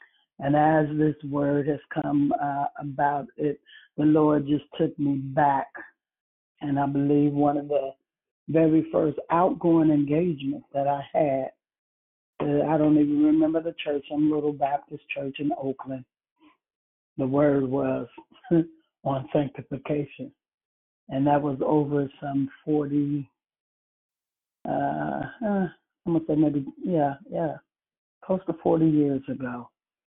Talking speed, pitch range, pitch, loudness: 125 wpm, 140-155 Hz, 145 Hz, -25 LUFS